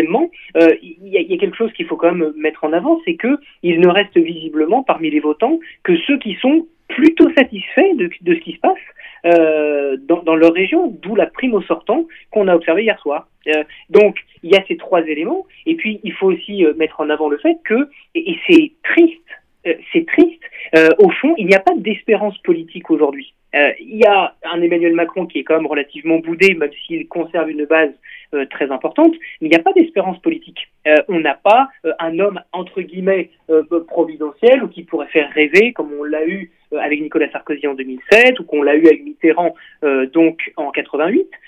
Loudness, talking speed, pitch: -15 LUFS, 220 wpm, 175 Hz